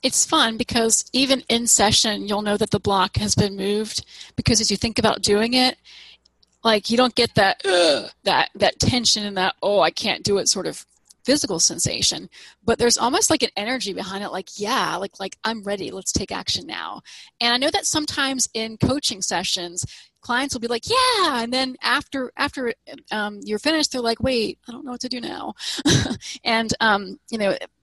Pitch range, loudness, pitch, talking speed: 210-260 Hz, -20 LUFS, 235 Hz, 200 wpm